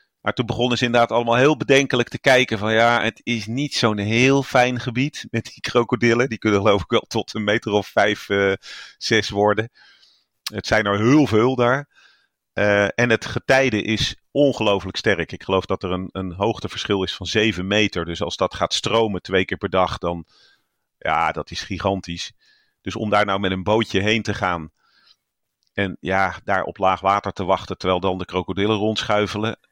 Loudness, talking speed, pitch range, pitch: -20 LUFS, 195 wpm, 95-120 Hz, 105 Hz